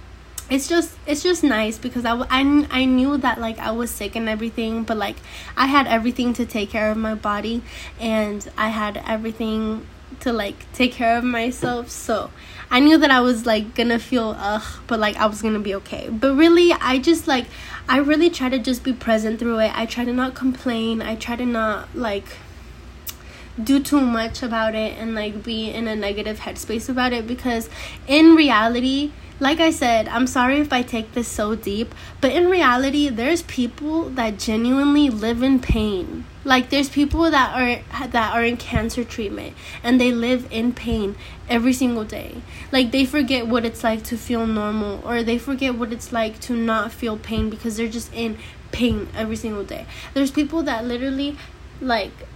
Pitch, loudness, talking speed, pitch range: 240 Hz, -20 LUFS, 190 wpm, 225-265 Hz